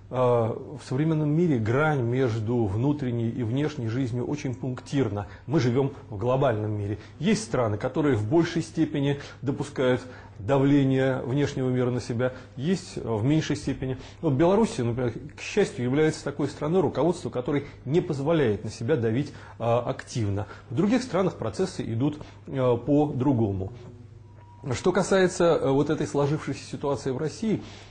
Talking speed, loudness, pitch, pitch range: 135 wpm, -26 LUFS, 130 Hz, 115-150 Hz